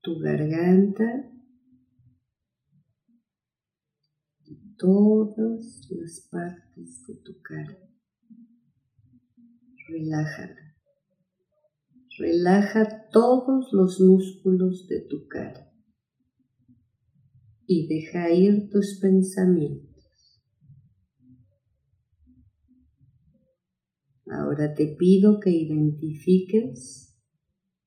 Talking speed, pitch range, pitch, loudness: 60 wpm, 125-200 Hz, 165 Hz, -22 LUFS